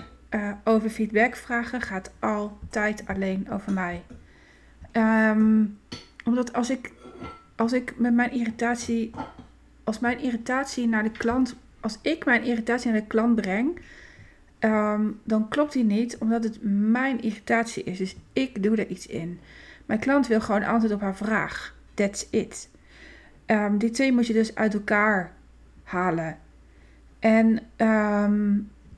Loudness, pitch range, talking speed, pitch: -25 LUFS, 210-235 Hz, 145 wpm, 220 Hz